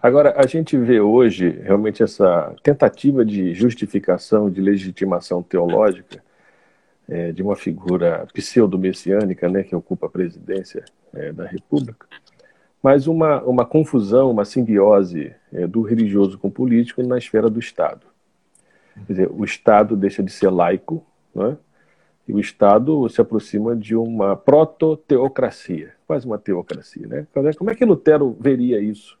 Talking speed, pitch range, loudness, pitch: 140 wpm, 100-140 Hz, -18 LUFS, 115 Hz